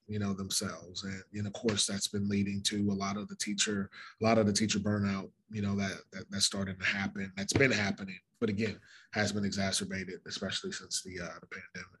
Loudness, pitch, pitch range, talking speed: -33 LUFS, 100 Hz, 100-105 Hz, 220 wpm